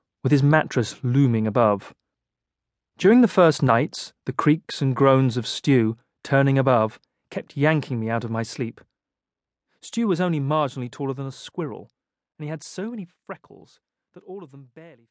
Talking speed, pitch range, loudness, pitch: 170 wpm, 120-160 Hz, -22 LUFS, 140 Hz